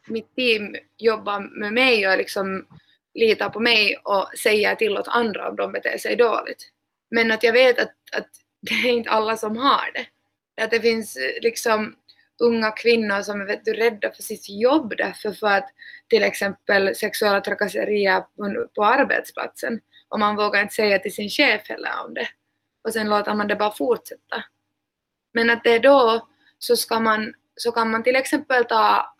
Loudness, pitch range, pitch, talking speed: -21 LUFS, 210-245 Hz, 225 Hz, 175 wpm